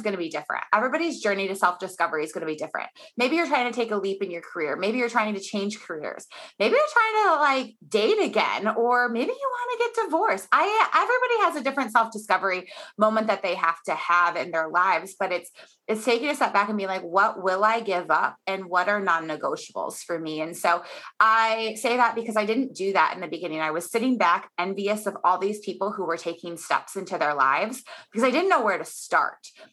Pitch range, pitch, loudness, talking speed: 180-245 Hz, 205 Hz, -24 LUFS, 235 wpm